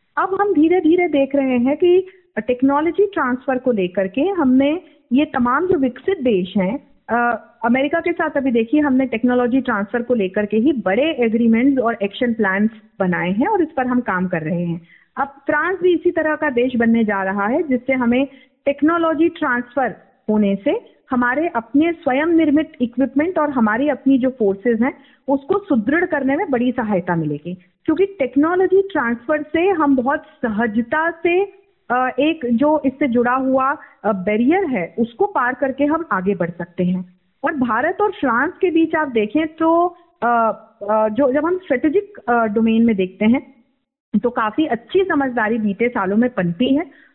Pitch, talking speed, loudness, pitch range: 265 Hz, 165 wpm, -18 LUFS, 230-310 Hz